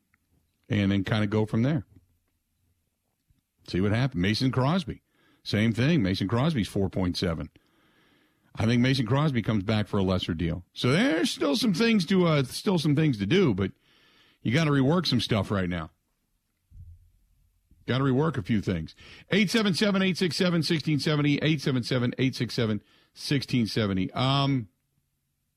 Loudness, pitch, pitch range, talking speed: -26 LUFS, 115 Hz, 95-150 Hz, 165 wpm